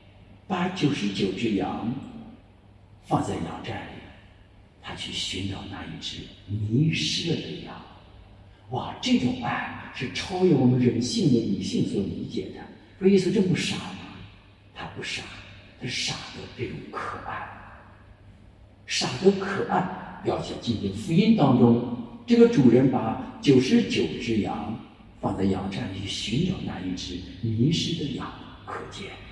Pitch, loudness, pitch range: 105 Hz, -25 LUFS, 95-130 Hz